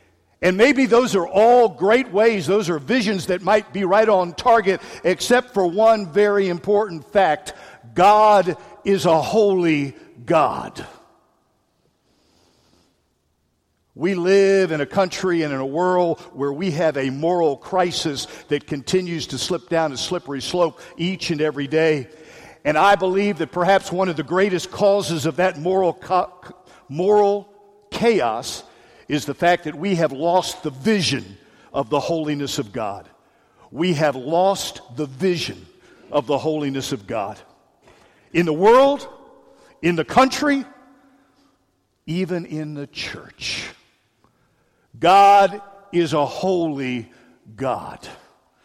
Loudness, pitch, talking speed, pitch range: -19 LUFS, 175 Hz, 135 wpm, 150-200 Hz